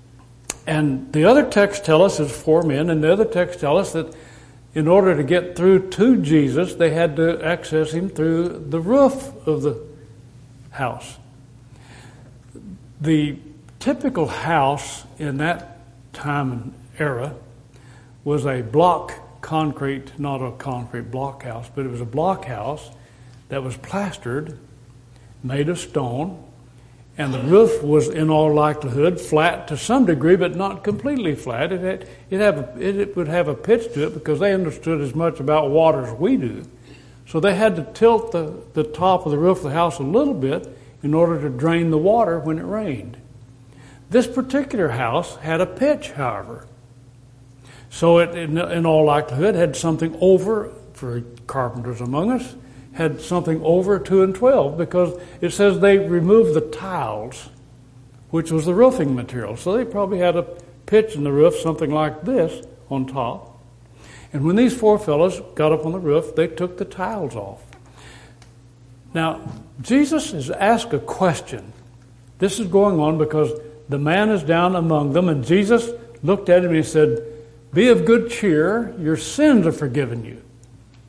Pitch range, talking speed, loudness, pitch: 125-180 Hz, 165 wpm, -19 LUFS, 155 Hz